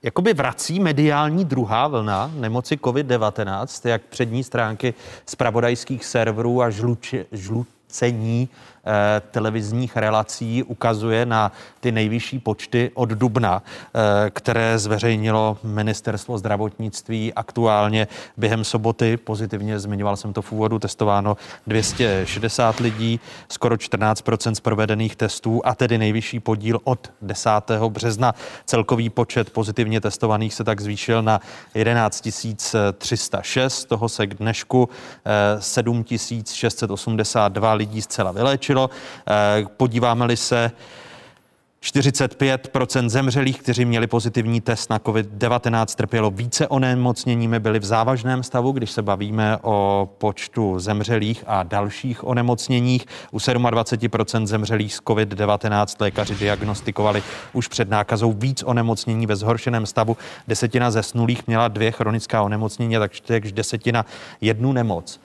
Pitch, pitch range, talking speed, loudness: 115 Hz, 110-120 Hz, 115 wpm, -21 LUFS